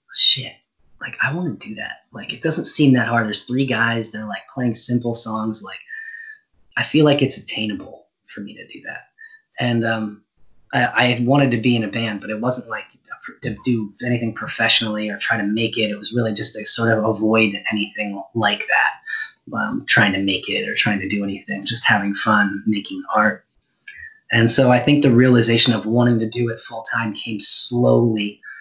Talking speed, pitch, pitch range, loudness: 200 wpm, 115 Hz, 105-125 Hz, -18 LUFS